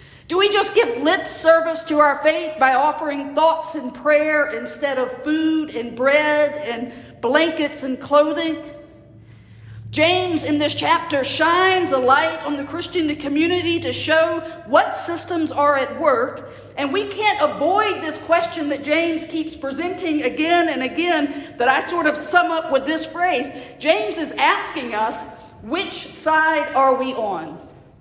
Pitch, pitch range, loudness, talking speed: 310 Hz, 280-330 Hz, -19 LUFS, 155 wpm